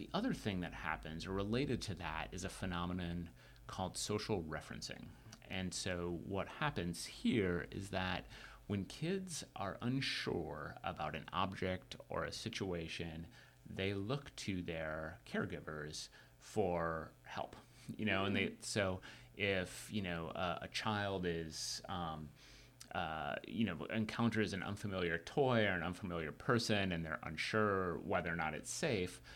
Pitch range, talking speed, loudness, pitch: 85-105 Hz, 145 wpm, -41 LUFS, 95 Hz